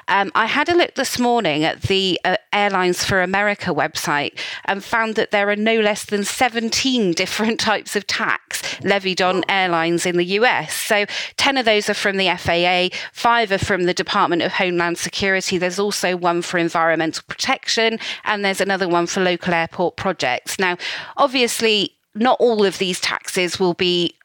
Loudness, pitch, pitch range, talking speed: -18 LUFS, 195 Hz, 180-215 Hz, 180 wpm